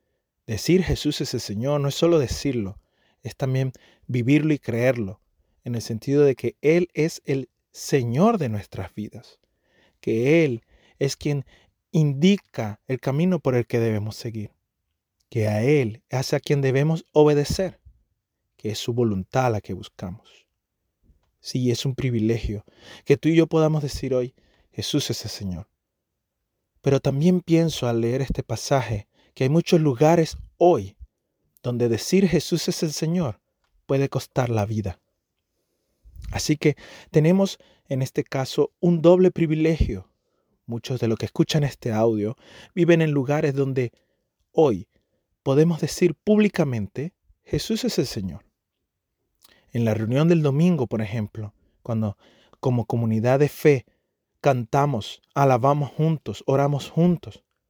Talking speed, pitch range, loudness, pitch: 140 wpm, 115-155 Hz, -23 LUFS, 135 Hz